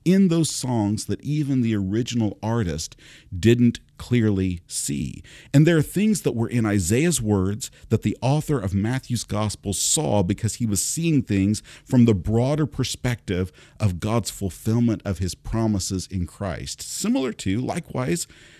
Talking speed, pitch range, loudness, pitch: 150 wpm, 100-130 Hz, -23 LUFS, 110 Hz